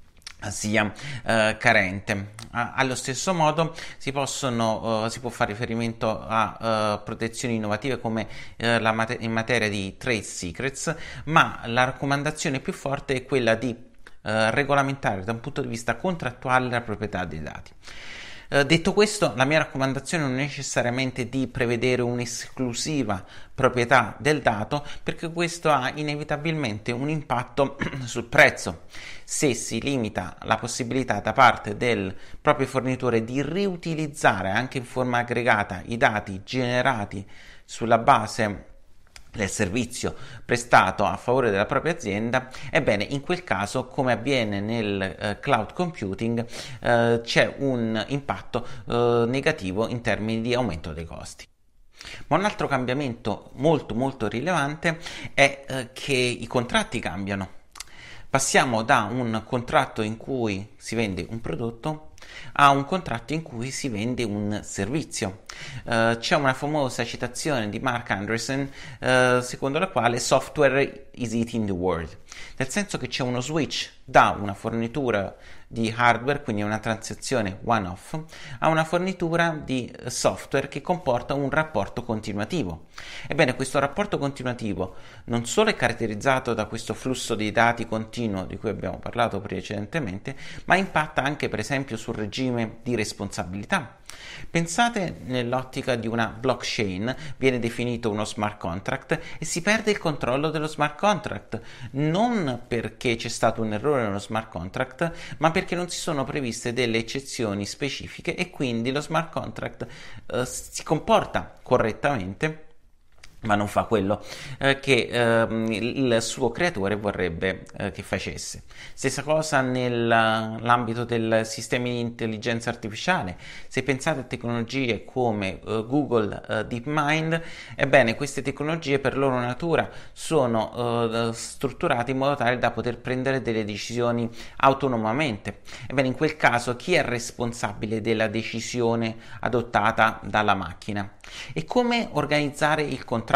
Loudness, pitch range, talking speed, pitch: -25 LUFS, 110-140 Hz, 140 wpm, 120 Hz